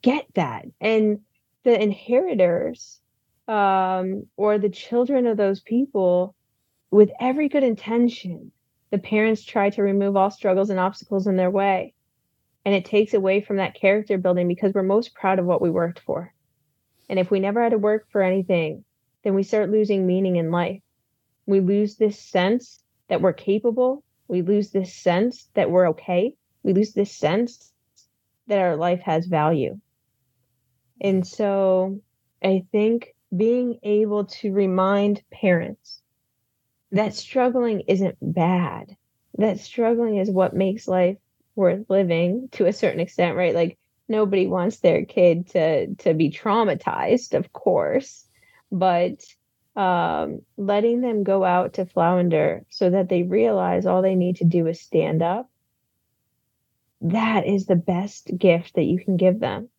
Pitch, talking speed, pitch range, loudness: 195 Hz, 150 wpm, 175-210 Hz, -22 LUFS